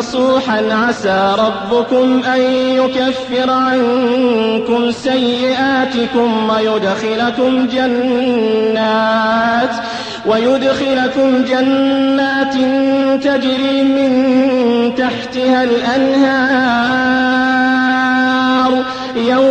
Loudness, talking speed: -13 LUFS, 50 wpm